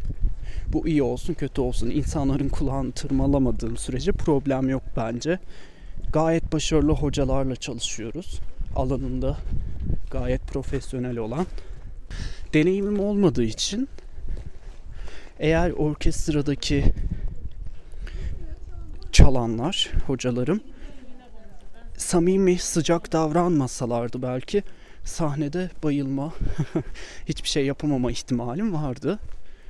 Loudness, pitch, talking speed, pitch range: -25 LUFS, 135 Hz, 75 wpm, 120-160 Hz